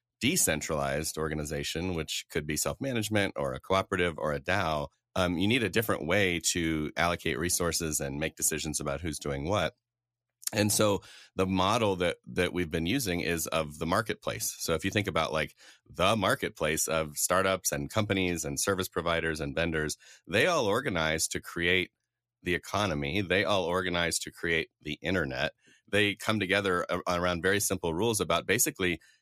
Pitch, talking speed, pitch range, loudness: 85 Hz, 170 wpm, 80-95 Hz, -29 LUFS